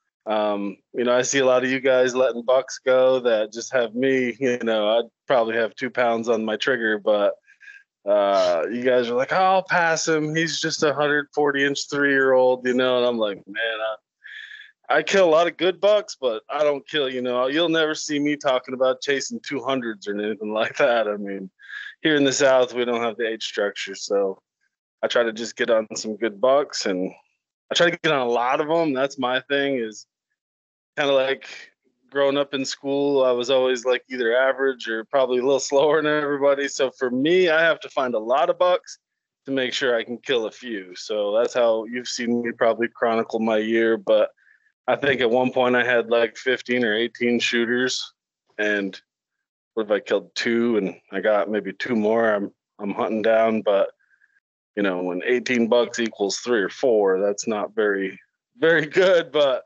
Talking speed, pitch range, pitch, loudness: 210 wpm, 115-145 Hz, 125 Hz, -22 LUFS